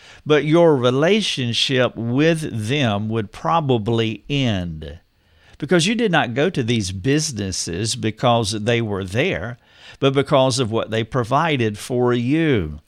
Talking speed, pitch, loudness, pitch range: 130 wpm, 120 Hz, -19 LUFS, 110-140 Hz